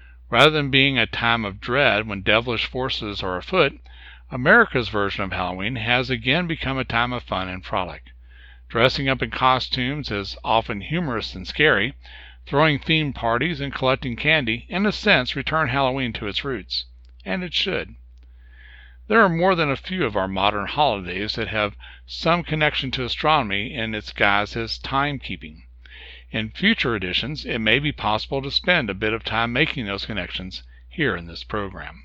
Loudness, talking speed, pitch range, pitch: -21 LUFS, 170 wpm, 95-135 Hz, 110 Hz